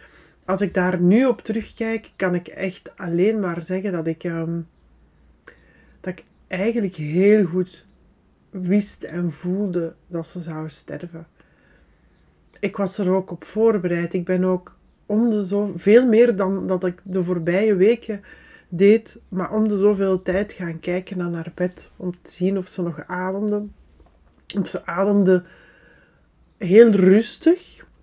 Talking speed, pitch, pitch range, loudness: 150 wpm, 185 Hz, 175-205 Hz, -21 LUFS